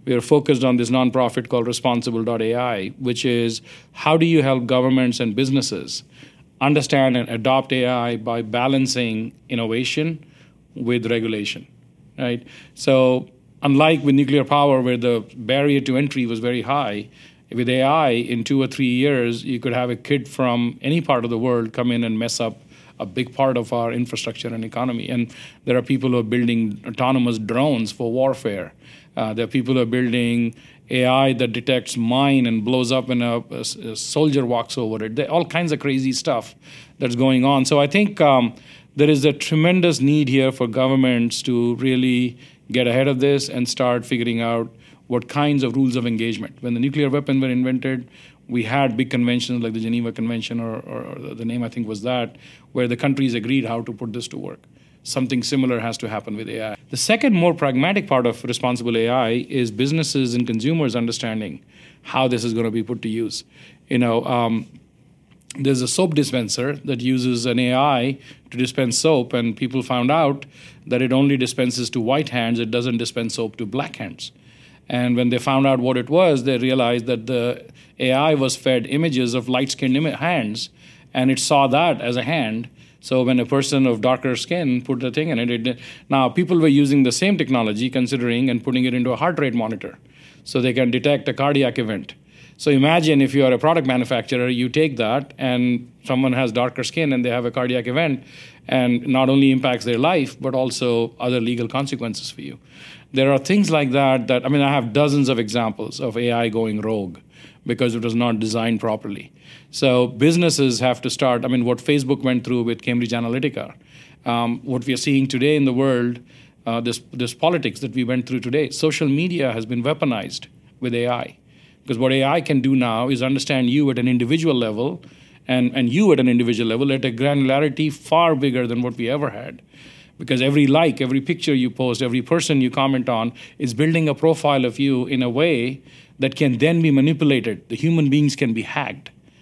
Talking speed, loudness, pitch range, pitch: 195 wpm, -20 LUFS, 120-140 Hz, 130 Hz